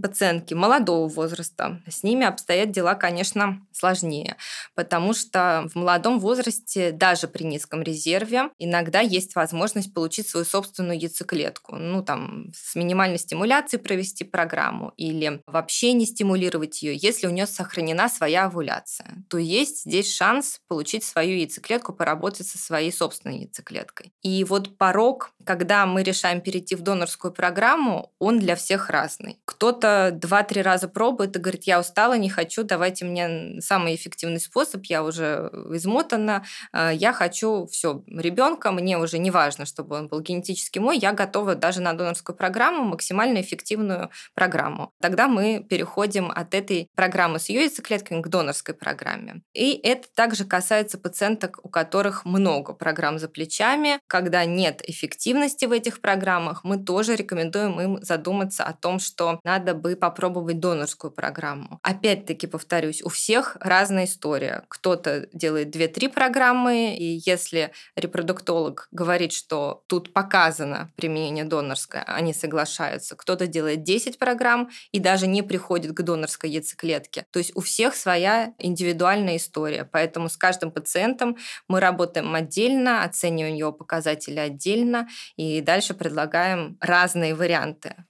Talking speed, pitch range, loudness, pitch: 140 wpm, 165-205 Hz, -23 LUFS, 180 Hz